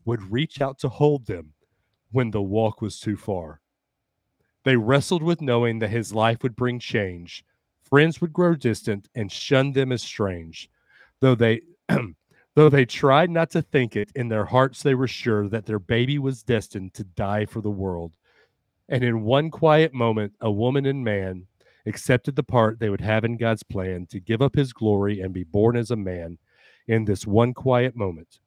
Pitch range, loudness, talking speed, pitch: 105-135 Hz, -23 LUFS, 190 wpm, 115 Hz